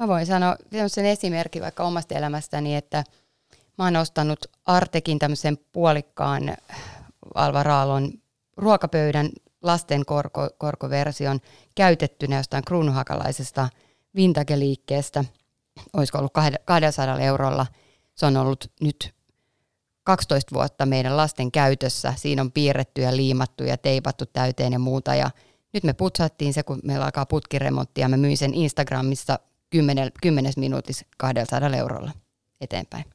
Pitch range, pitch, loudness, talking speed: 130-155 Hz, 140 Hz, -23 LUFS, 120 wpm